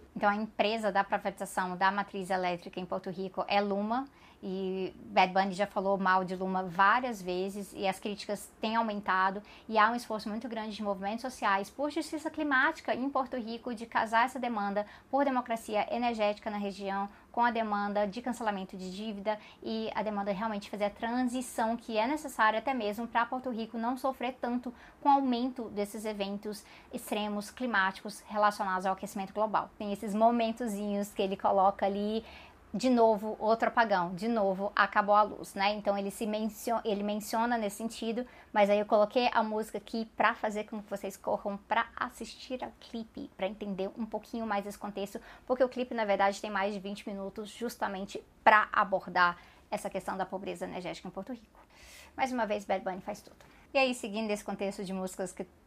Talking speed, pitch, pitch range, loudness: 190 wpm, 210 Hz, 200-230 Hz, -32 LUFS